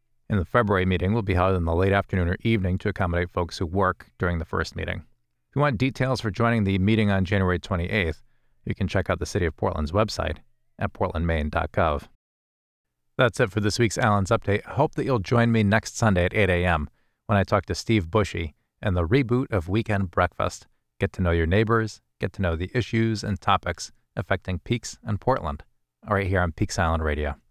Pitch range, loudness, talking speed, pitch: 85-110 Hz, -25 LUFS, 210 wpm, 95 Hz